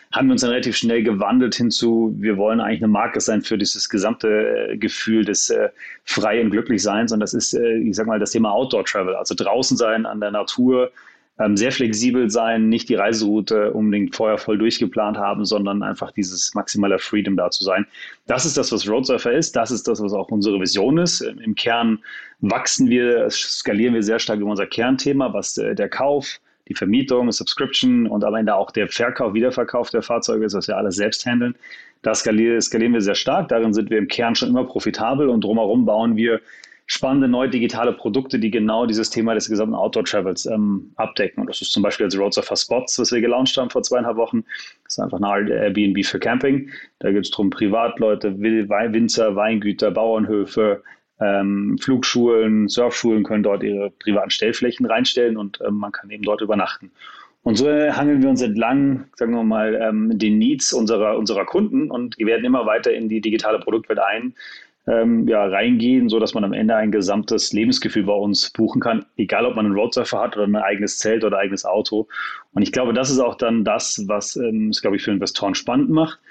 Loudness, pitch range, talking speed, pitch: -19 LUFS, 105-125 Hz, 195 wpm, 110 Hz